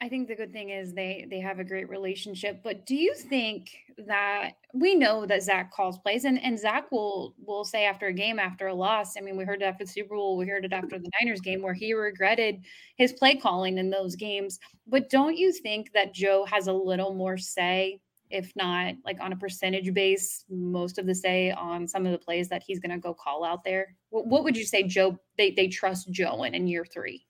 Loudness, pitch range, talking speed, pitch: -28 LUFS, 185-215 Hz, 240 wpm, 195 Hz